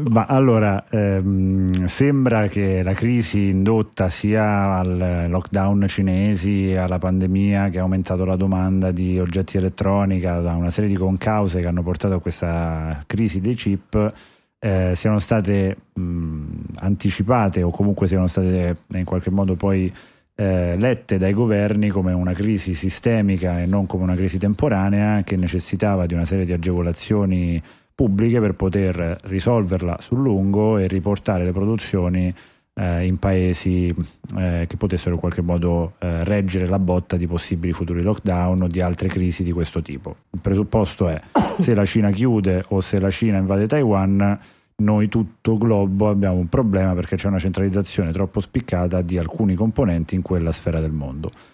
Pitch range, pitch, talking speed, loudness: 90-100 Hz, 95 Hz, 160 wpm, -20 LUFS